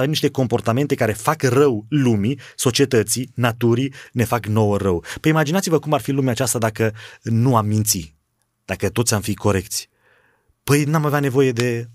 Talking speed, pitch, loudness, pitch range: 165 wpm, 120 Hz, -19 LUFS, 110-140 Hz